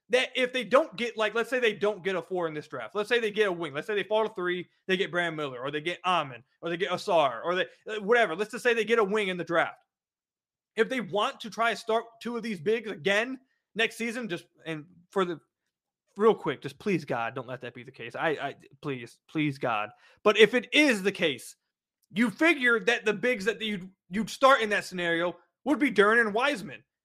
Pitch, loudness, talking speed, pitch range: 210 Hz, -27 LUFS, 245 wpm, 170-230 Hz